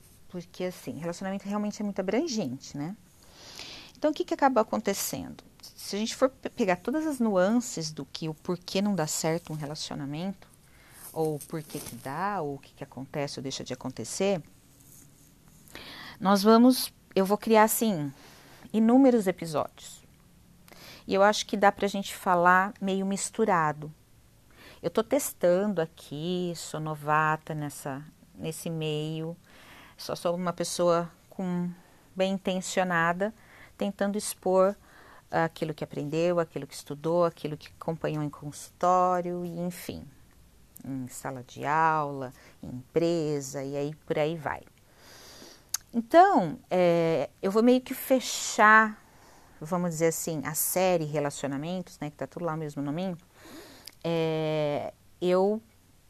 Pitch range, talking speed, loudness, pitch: 150-195 Hz, 135 wpm, -28 LUFS, 170 Hz